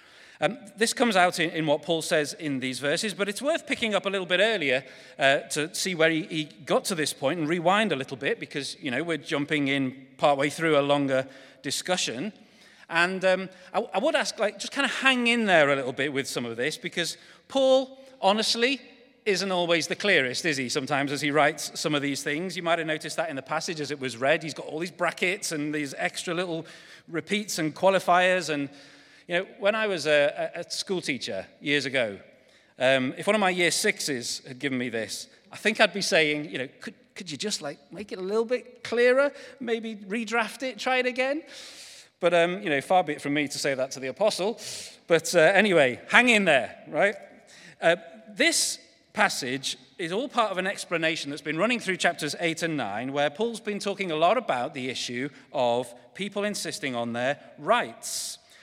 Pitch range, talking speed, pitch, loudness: 145-210 Hz, 215 wpm, 170 Hz, -26 LUFS